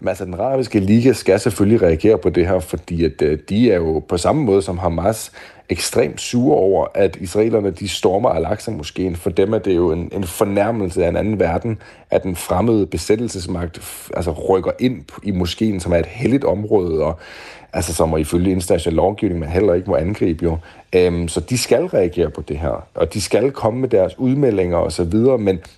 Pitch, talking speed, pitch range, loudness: 95 Hz, 205 wpm, 85-110 Hz, -18 LUFS